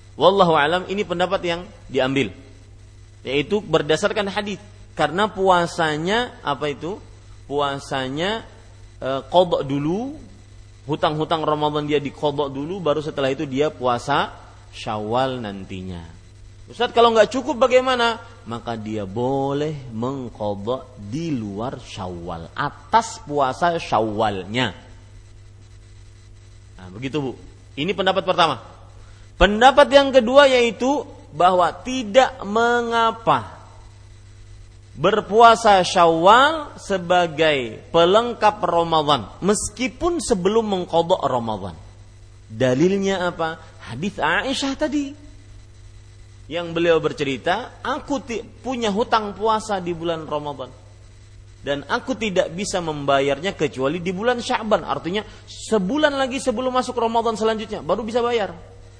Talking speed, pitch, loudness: 100 wpm, 150 Hz, -20 LUFS